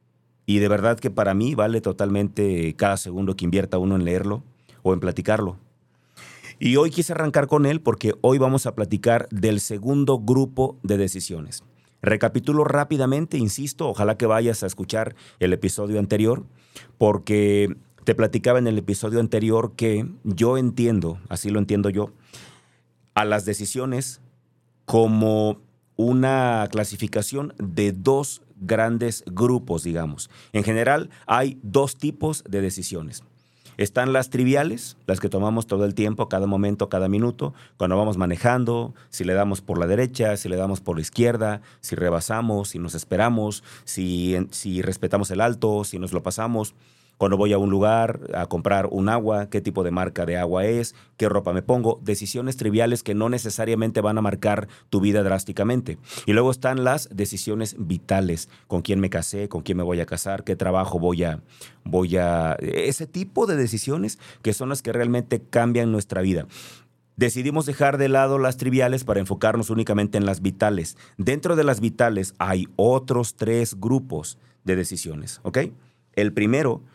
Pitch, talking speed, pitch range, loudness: 105 Hz, 165 wpm, 95-120 Hz, -23 LUFS